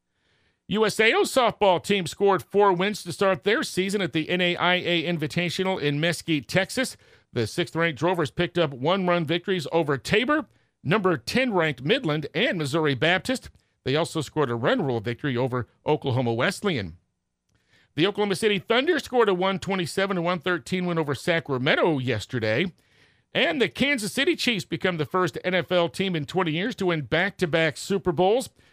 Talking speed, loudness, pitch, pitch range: 165 wpm, -24 LUFS, 175 Hz, 155-195 Hz